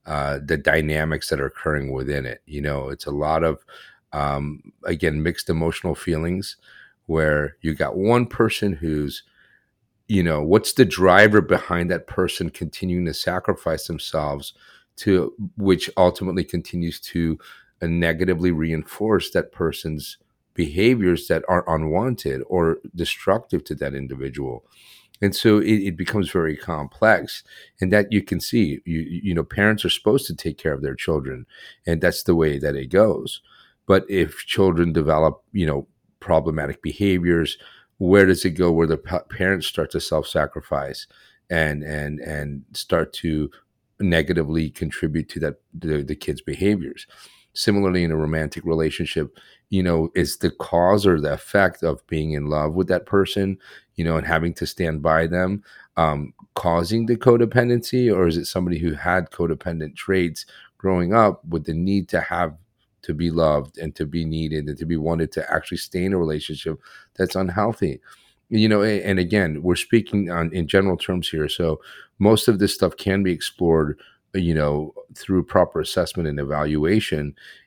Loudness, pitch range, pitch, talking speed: -22 LUFS, 75-95 Hz, 85 Hz, 160 wpm